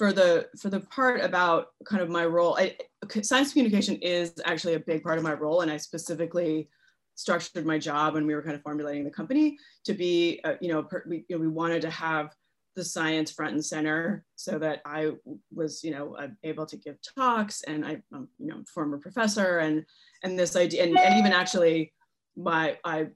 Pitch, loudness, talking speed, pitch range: 170 Hz, -27 LUFS, 210 wpm, 155-190 Hz